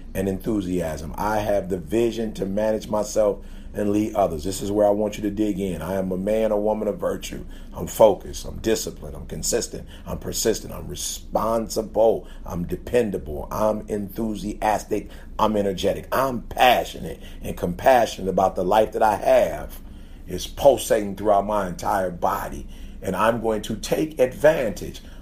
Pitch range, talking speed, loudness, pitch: 90-110 Hz, 160 wpm, -23 LUFS, 105 Hz